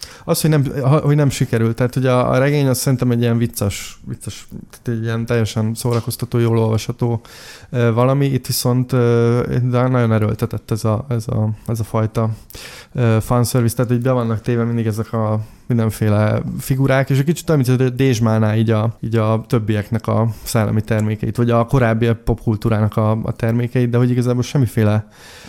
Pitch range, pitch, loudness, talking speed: 110-125 Hz, 115 Hz, -17 LUFS, 165 wpm